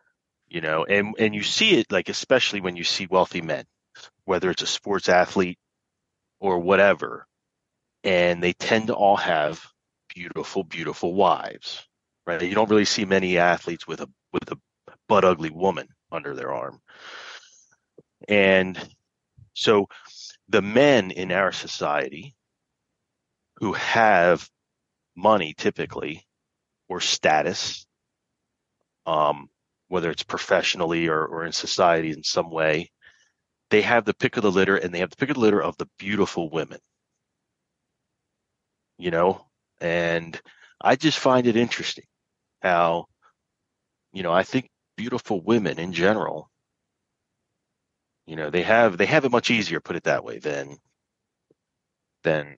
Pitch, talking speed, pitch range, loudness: 95 Hz, 140 wpm, 85-110 Hz, -22 LUFS